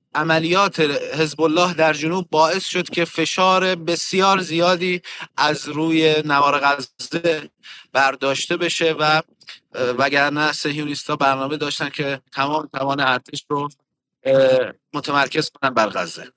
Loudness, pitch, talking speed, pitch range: -19 LUFS, 155 Hz, 115 wpm, 140-165 Hz